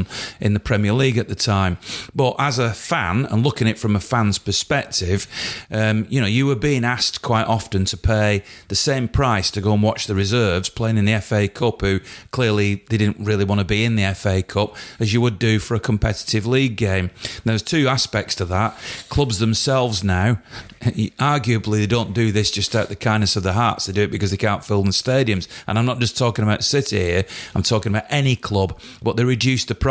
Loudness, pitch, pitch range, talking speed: -19 LUFS, 110 Hz, 100-120 Hz, 230 wpm